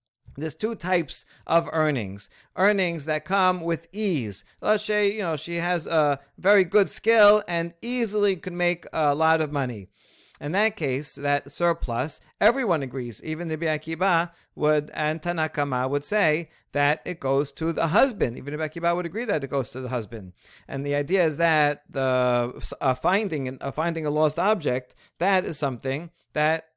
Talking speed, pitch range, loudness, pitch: 175 wpm, 140-180 Hz, -25 LUFS, 155 Hz